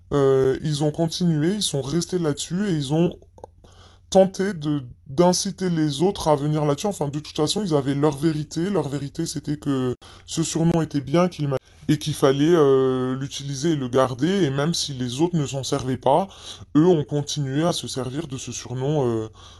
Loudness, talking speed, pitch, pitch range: -22 LUFS, 195 wpm, 145 Hz, 130-165 Hz